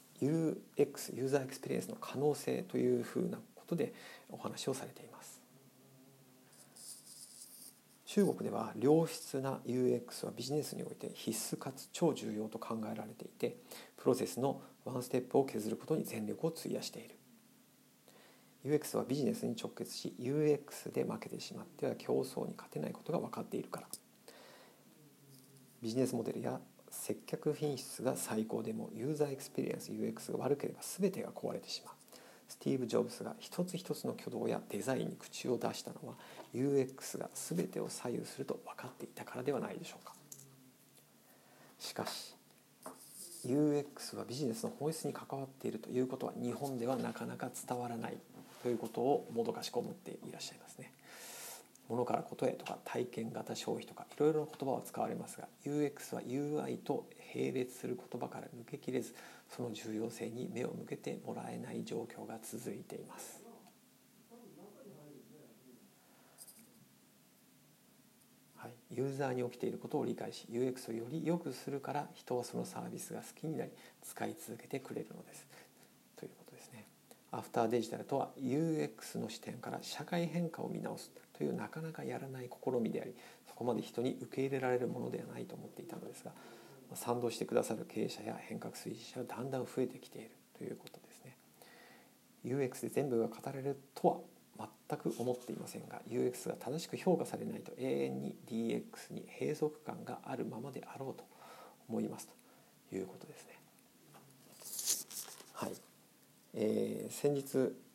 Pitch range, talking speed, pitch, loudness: 120-145 Hz, 340 characters per minute, 130 Hz, -40 LUFS